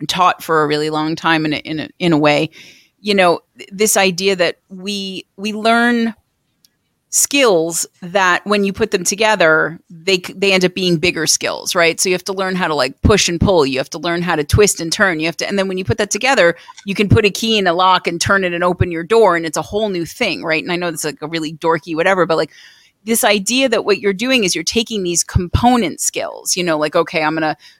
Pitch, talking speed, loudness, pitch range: 180 Hz, 255 wpm, -15 LUFS, 165-205 Hz